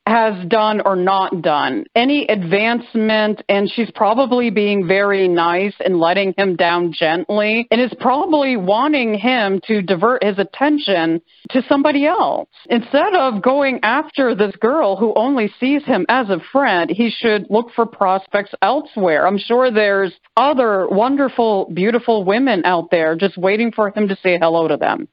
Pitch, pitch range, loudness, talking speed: 210 Hz, 195-245 Hz, -16 LUFS, 160 wpm